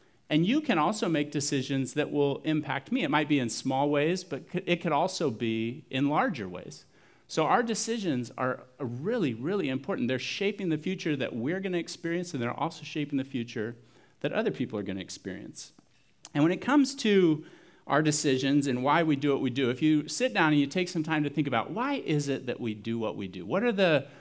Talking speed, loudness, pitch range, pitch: 225 wpm, -29 LUFS, 130-170 Hz, 145 Hz